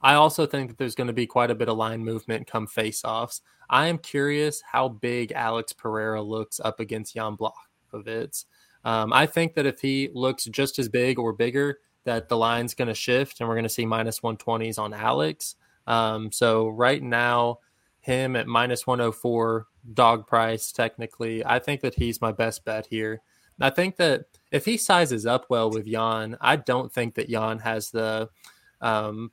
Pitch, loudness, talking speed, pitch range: 115 Hz, -25 LUFS, 190 wpm, 110-125 Hz